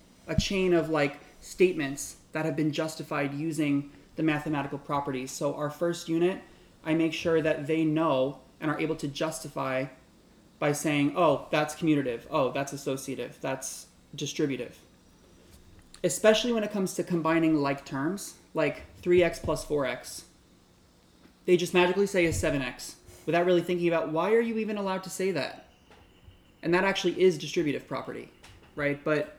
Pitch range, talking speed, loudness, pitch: 140-175 Hz, 155 wpm, -28 LUFS, 155 Hz